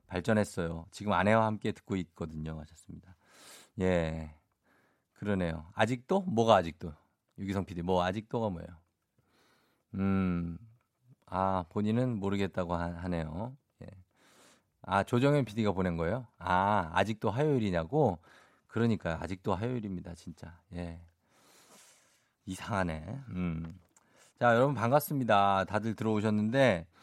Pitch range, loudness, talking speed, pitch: 85-110 Hz, -31 LUFS, 275 characters per minute, 95 Hz